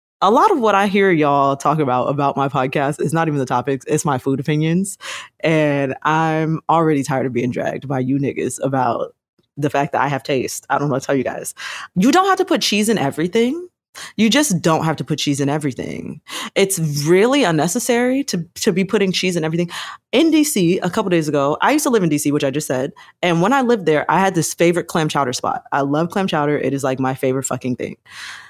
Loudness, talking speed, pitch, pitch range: -18 LUFS, 240 wpm, 155 Hz, 140-195 Hz